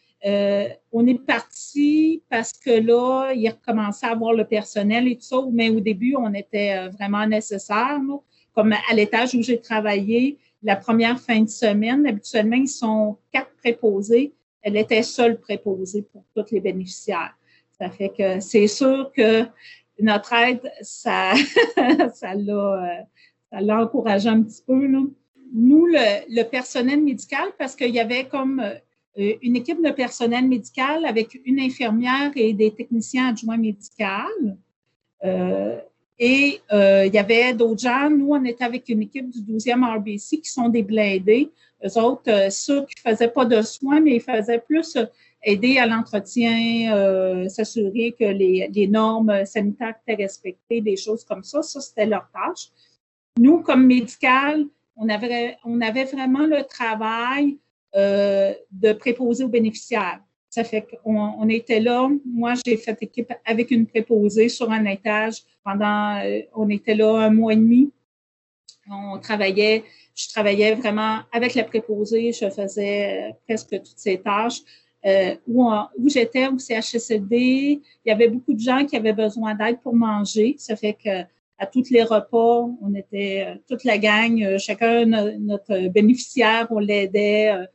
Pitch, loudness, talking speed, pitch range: 225 Hz, -20 LUFS, 160 wpm, 210-250 Hz